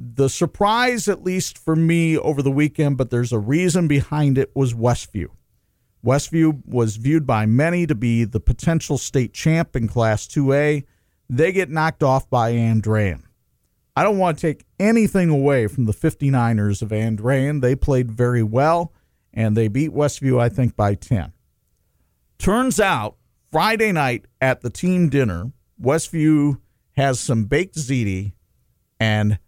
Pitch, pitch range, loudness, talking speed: 135 Hz, 115-160 Hz, -19 LUFS, 155 wpm